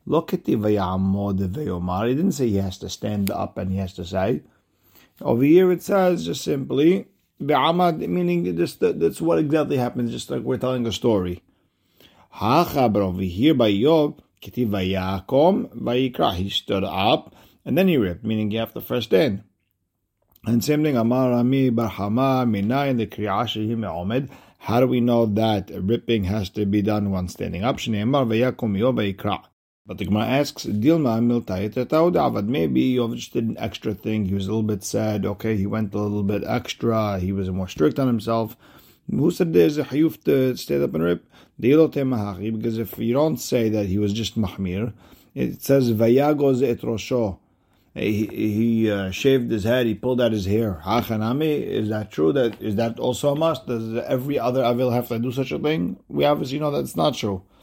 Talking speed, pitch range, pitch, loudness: 155 wpm, 100-125 Hz, 110 Hz, -22 LUFS